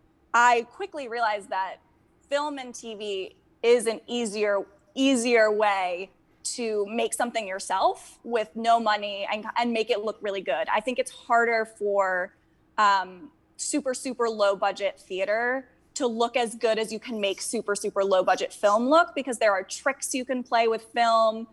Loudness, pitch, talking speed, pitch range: -26 LUFS, 225 Hz, 165 wpm, 205-245 Hz